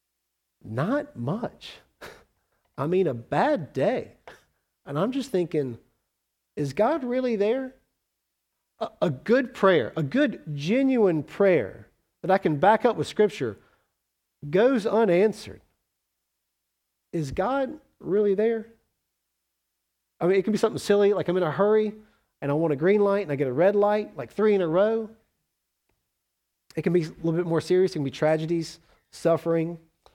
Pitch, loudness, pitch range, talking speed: 175 Hz, -25 LUFS, 145-210 Hz, 155 wpm